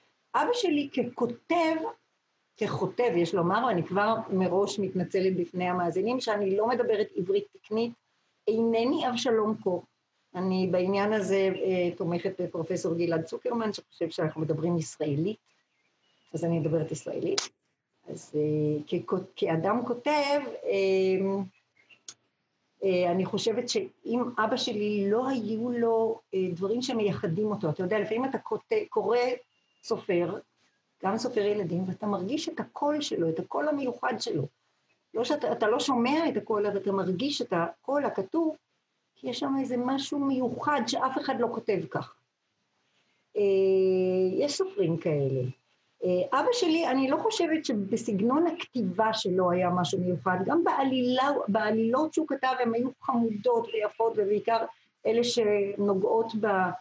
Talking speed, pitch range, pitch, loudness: 135 wpm, 185-260 Hz, 215 Hz, -28 LUFS